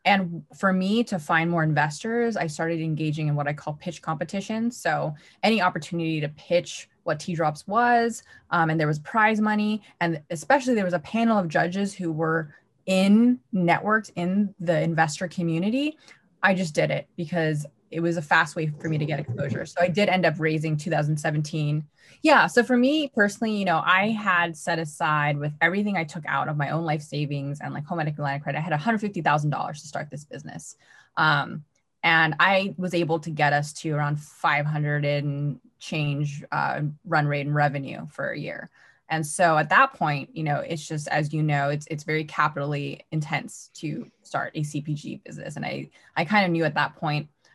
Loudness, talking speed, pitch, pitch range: -25 LUFS, 195 wpm, 160 Hz, 150-185 Hz